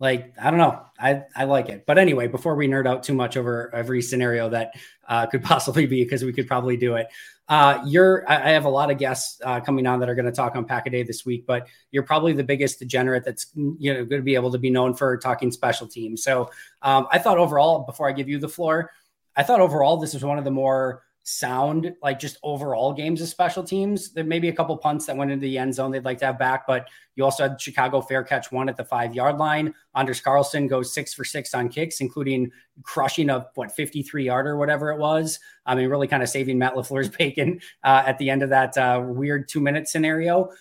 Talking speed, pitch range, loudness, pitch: 250 wpm, 130-150 Hz, -22 LUFS, 135 Hz